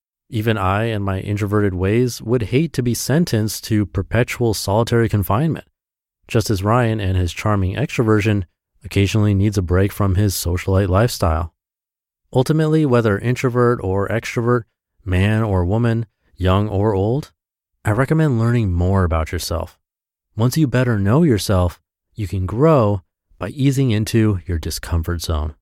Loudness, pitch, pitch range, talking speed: -18 LUFS, 105 Hz, 95-120 Hz, 145 wpm